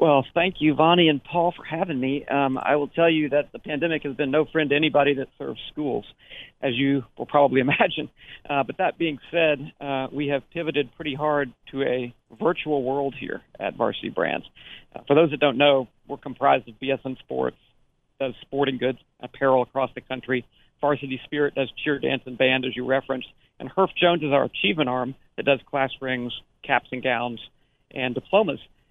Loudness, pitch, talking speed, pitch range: -24 LUFS, 140 Hz, 195 wpm, 130-150 Hz